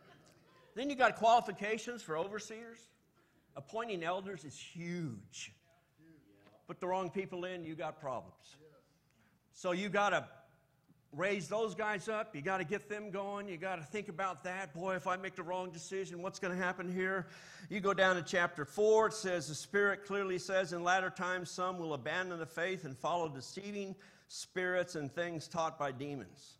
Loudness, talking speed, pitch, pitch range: -37 LUFS, 180 wpm, 180 Hz, 160-195 Hz